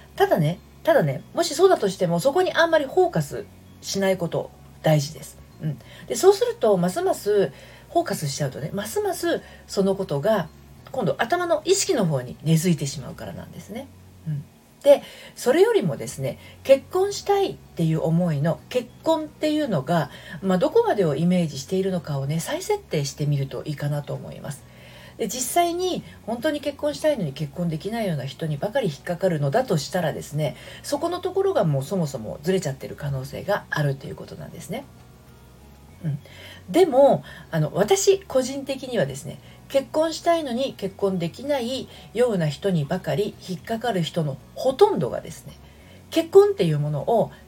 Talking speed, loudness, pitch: 375 characters per minute, -23 LUFS, 190 Hz